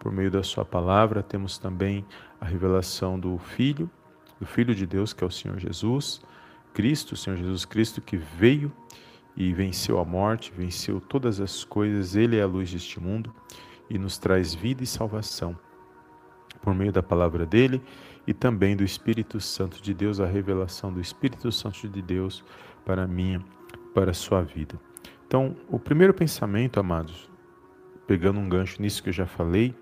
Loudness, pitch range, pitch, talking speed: -26 LUFS, 90-110 Hz, 95 Hz, 170 wpm